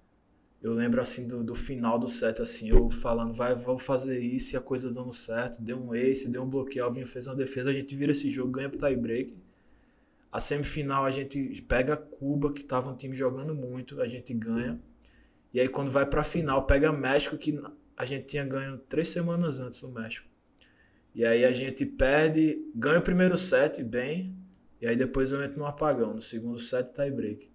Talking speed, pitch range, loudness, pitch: 200 wpm, 125-145 Hz, -29 LUFS, 135 Hz